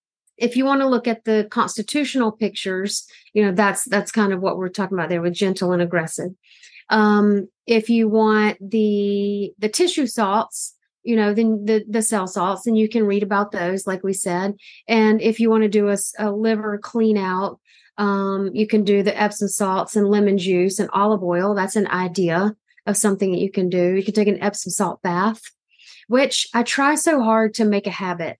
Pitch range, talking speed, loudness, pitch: 195-220 Hz, 205 wpm, -20 LUFS, 205 Hz